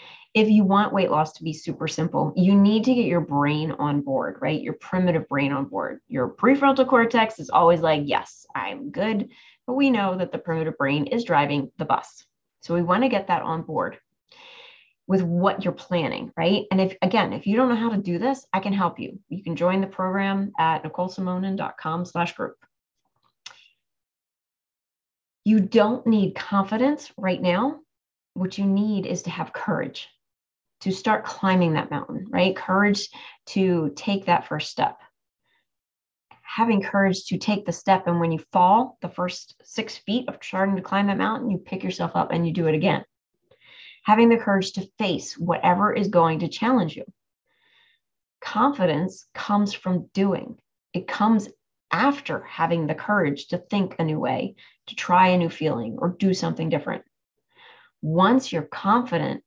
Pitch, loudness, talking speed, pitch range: 190 Hz, -23 LUFS, 175 wpm, 175-220 Hz